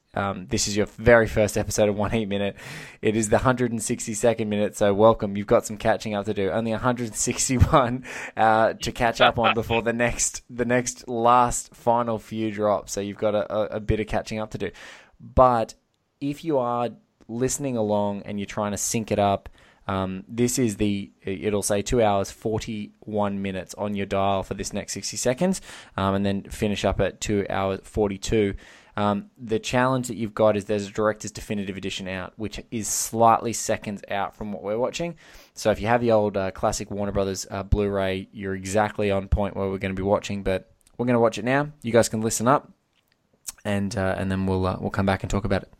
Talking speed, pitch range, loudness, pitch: 230 wpm, 100-115 Hz, -24 LUFS, 105 Hz